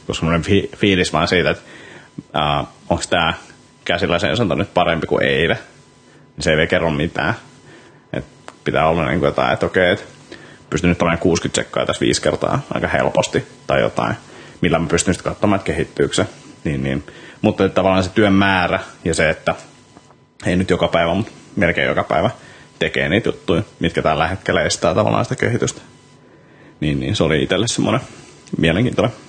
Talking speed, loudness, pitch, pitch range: 170 wpm, -18 LUFS, 85 Hz, 80-95 Hz